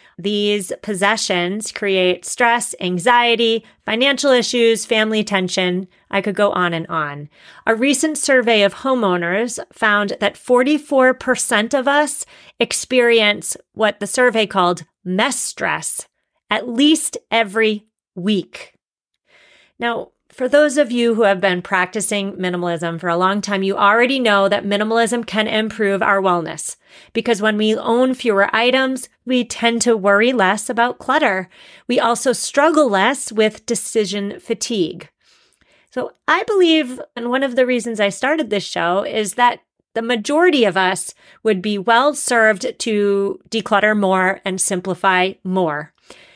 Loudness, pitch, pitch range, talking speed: -17 LUFS, 220 Hz, 195-245 Hz, 140 wpm